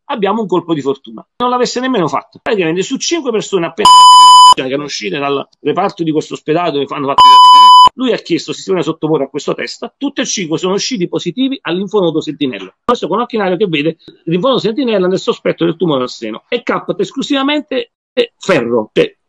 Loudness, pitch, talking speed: -11 LUFS, 200 Hz, 170 wpm